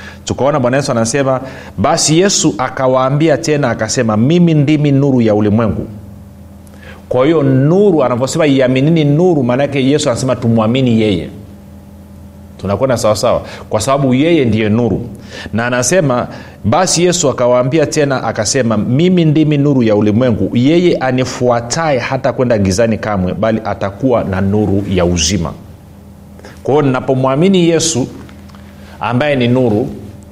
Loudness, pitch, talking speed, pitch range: -12 LUFS, 120 Hz, 125 wpm, 100-140 Hz